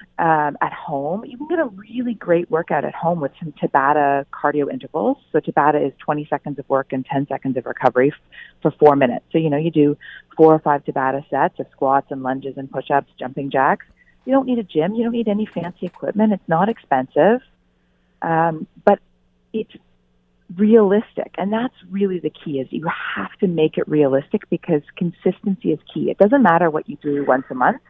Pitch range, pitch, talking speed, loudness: 140-190 Hz, 155 Hz, 200 wpm, -19 LUFS